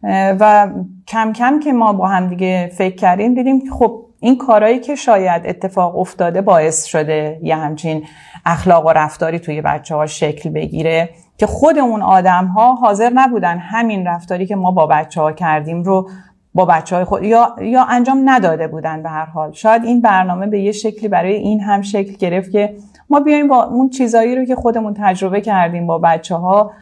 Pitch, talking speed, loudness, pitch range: 190 Hz, 185 wpm, -14 LUFS, 170-225 Hz